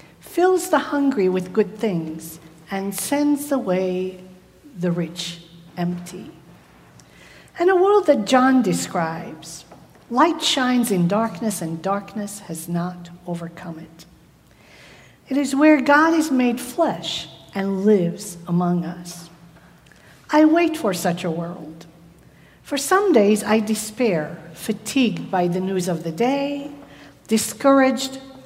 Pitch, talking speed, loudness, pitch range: 195 Hz, 120 wpm, -20 LUFS, 170-265 Hz